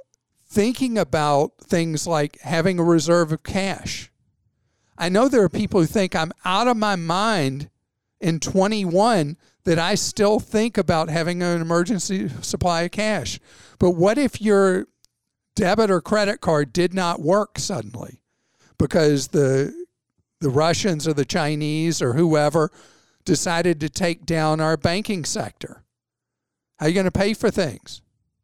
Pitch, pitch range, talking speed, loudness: 170 Hz, 155-200 Hz, 150 wpm, -21 LUFS